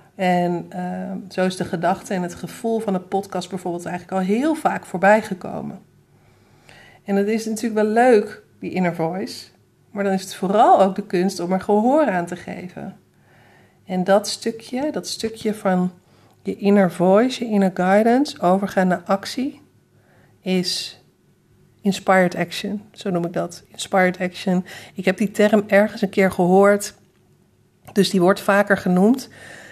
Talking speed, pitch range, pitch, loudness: 160 wpm, 185-210 Hz, 195 Hz, -20 LUFS